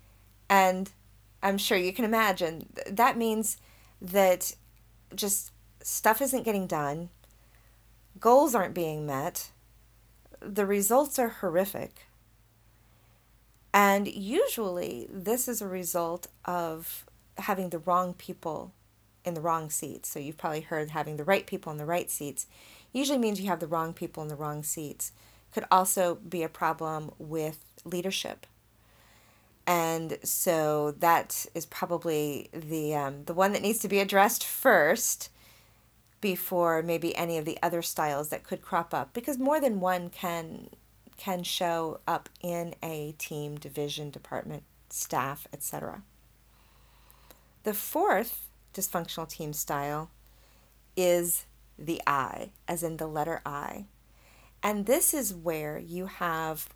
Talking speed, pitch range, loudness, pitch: 135 wpm, 145-190 Hz, -29 LUFS, 165 Hz